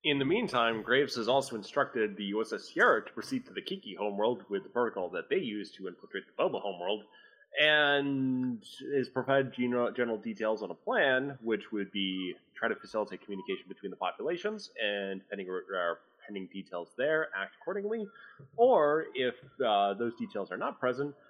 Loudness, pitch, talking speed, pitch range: -32 LUFS, 130 Hz, 170 wpm, 110-155 Hz